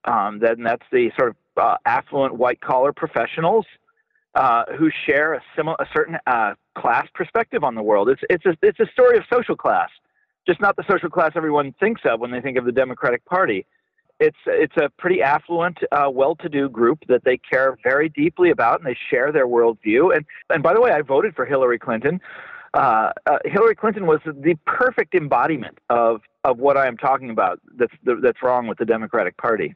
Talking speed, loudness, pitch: 200 wpm, -19 LUFS, 175 Hz